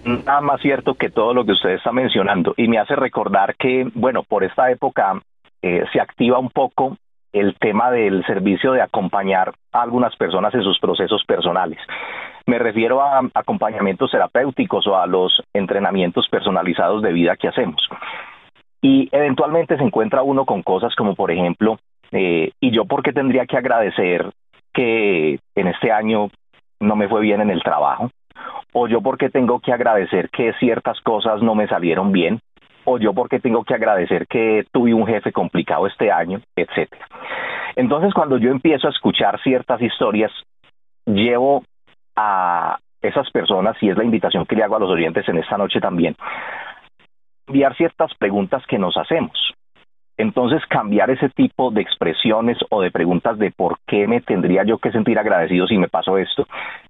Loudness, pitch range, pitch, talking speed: -18 LUFS, 105-135 Hz, 120 Hz, 170 wpm